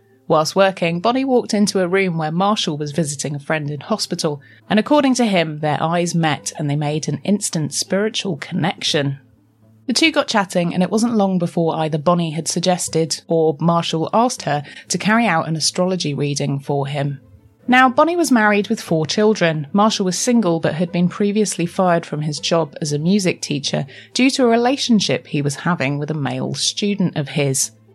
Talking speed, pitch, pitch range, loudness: 190 wpm, 170 Hz, 150-205 Hz, -18 LUFS